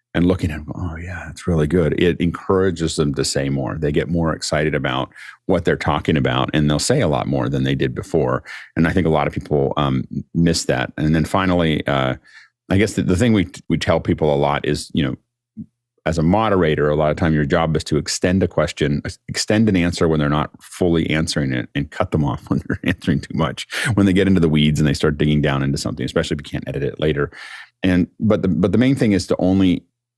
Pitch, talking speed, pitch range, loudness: 80 Hz, 245 wpm, 75-90 Hz, -19 LUFS